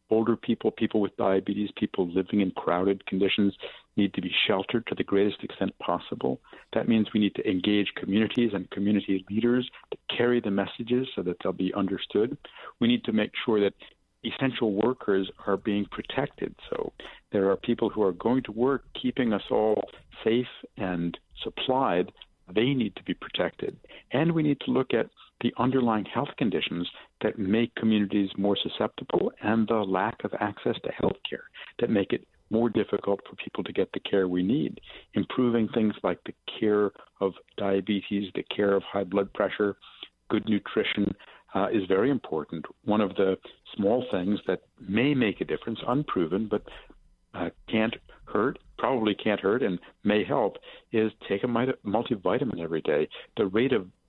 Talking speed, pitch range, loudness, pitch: 170 wpm, 100-115 Hz, -28 LUFS, 105 Hz